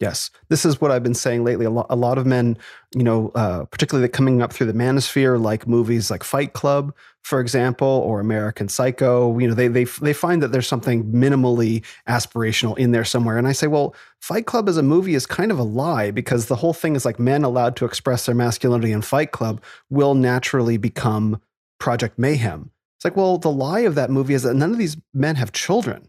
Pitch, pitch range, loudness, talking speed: 125 Hz, 115-140 Hz, -20 LUFS, 220 wpm